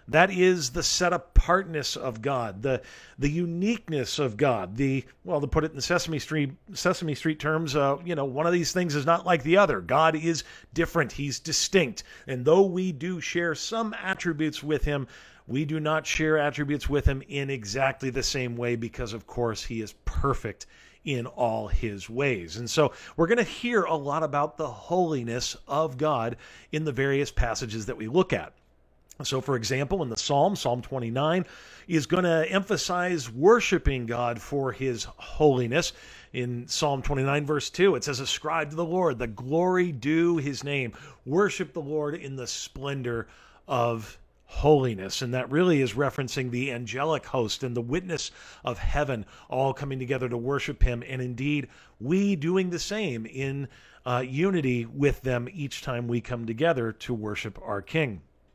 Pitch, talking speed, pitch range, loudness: 140 Hz, 175 wpm, 125-165 Hz, -27 LUFS